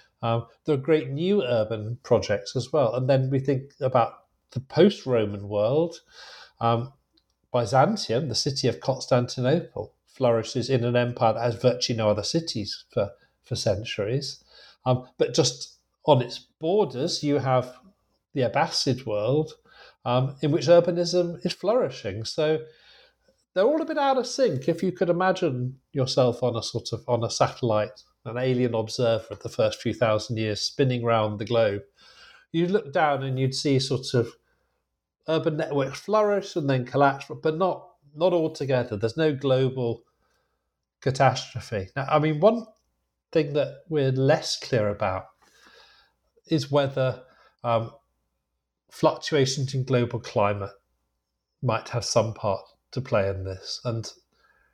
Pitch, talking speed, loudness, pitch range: 130 Hz, 150 wpm, -25 LUFS, 115-155 Hz